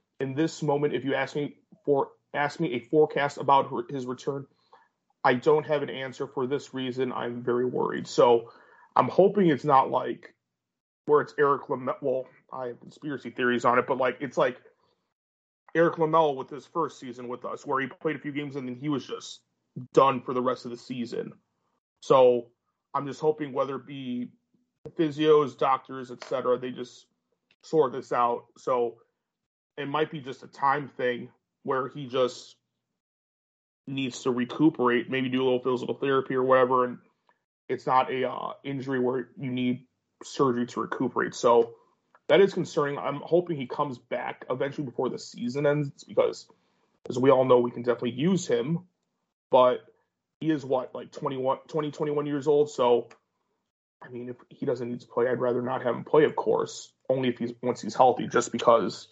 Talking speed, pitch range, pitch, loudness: 190 wpm, 125-150 Hz, 135 Hz, -27 LUFS